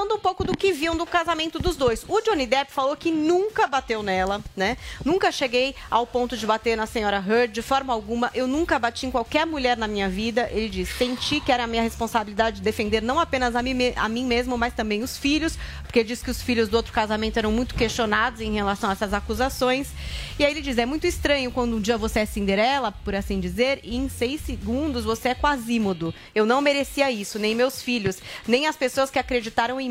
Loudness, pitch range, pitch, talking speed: -24 LUFS, 225-275 Hz, 245 Hz, 220 wpm